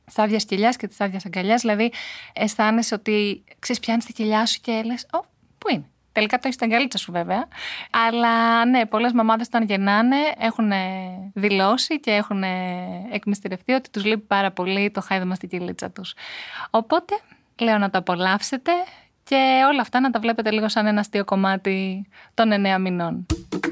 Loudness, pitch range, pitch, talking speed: -22 LUFS, 195-235 Hz, 215 Hz, 165 wpm